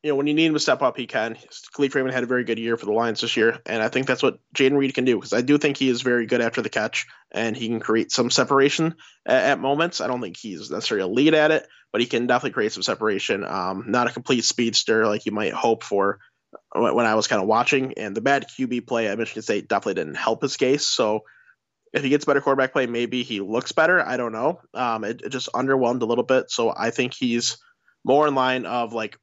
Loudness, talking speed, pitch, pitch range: -22 LUFS, 265 wpm, 125 Hz, 115-140 Hz